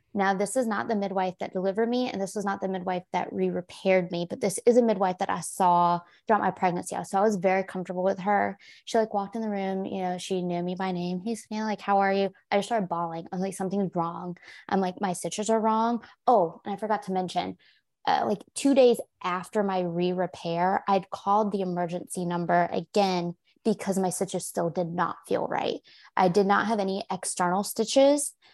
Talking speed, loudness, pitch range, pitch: 220 wpm, -27 LUFS, 180-205 Hz, 190 Hz